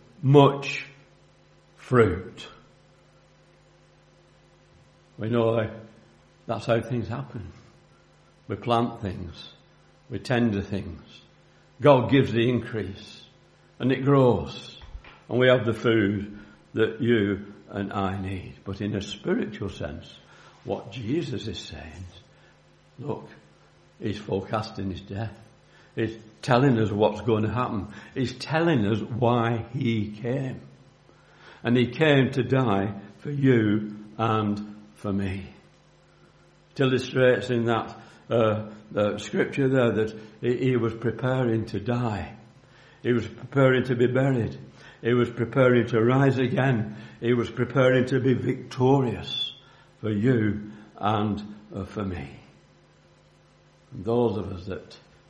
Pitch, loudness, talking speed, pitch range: 115 Hz, -25 LUFS, 120 wpm, 105-125 Hz